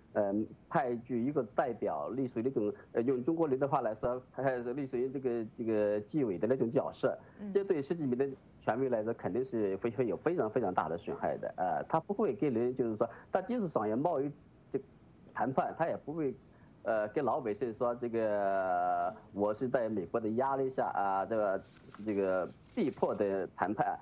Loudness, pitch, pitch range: -34 LUFS, 120 Hz, 105-135 Hz